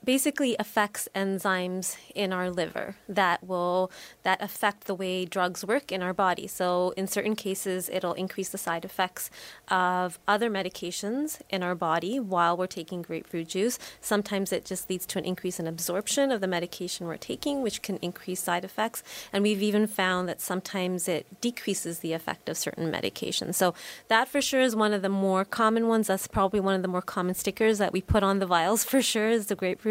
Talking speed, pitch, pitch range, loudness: 200 wpm, 190 Hz, 180-210 Hz, -28 LUFS